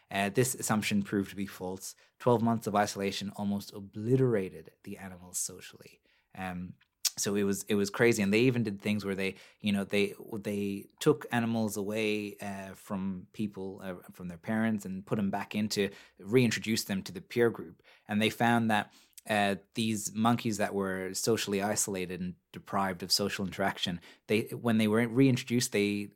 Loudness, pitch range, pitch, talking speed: -31 LUFS, 100-110 Hz, 105 Hz, 175 wpm